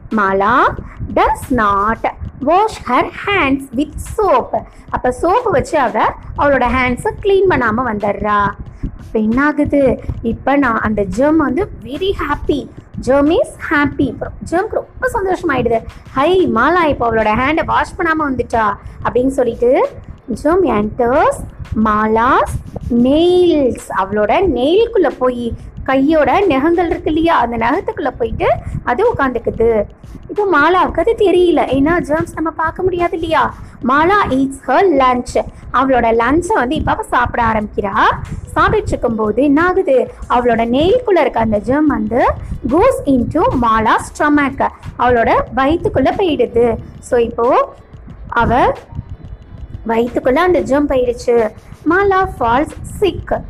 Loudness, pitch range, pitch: -14 LUFS, 240-355 Hz, 280 Hz